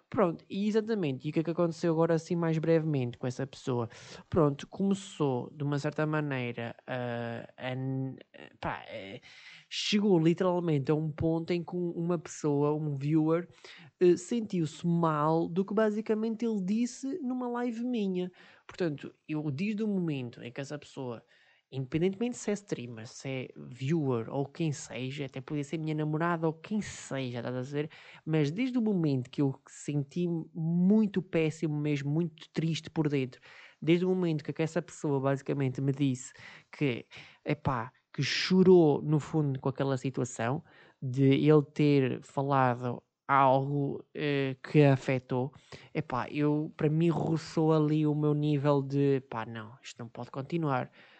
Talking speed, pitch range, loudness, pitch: 155 wpm, 135-170 Hz, -31 LUFS, 150 Hz